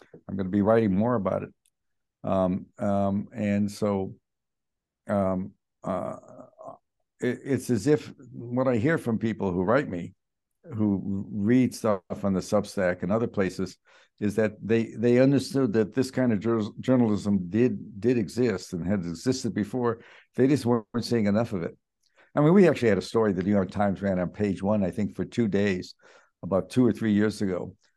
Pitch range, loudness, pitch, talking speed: 100-120 Hz, -26 LUFS, 105 Hz, 185 wpm